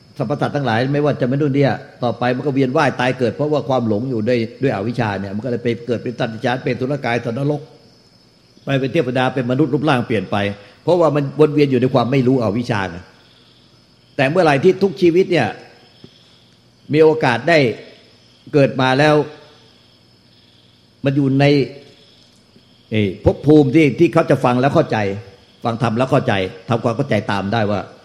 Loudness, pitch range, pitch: -17 LUFS, 115-145 Hz, 130 Hz